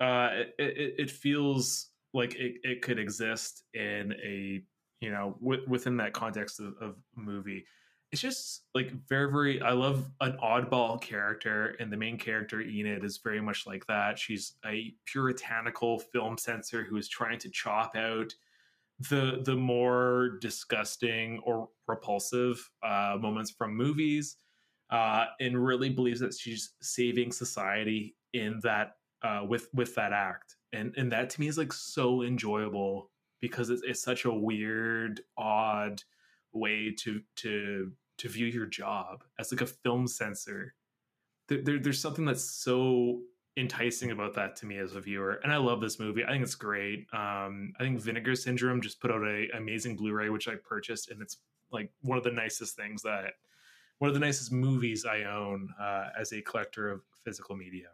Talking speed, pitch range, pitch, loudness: 170 wpm, 105-125 Hz, 115 Hz, -33 LUFS